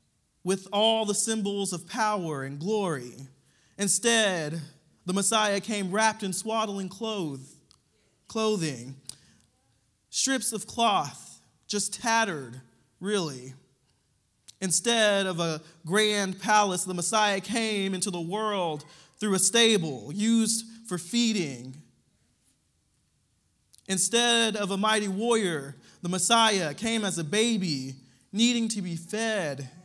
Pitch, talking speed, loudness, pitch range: 195 Hz, 110 wpm, -26 LUFS, 150-215 Hz